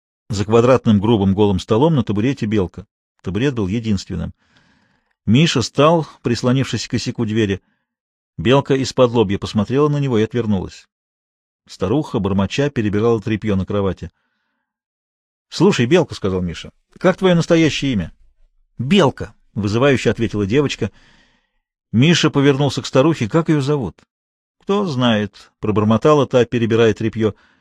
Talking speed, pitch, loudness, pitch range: 120 wpm, 115 Hz, -17 LUFS, 100-140 Hz